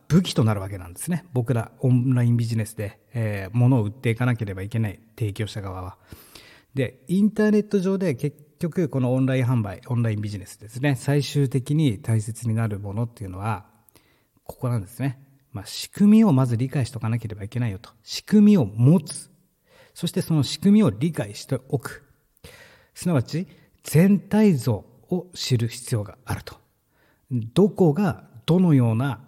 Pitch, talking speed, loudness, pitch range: 125 Hz, 355 characters per minute, -23 LUFS, 110-155 Hz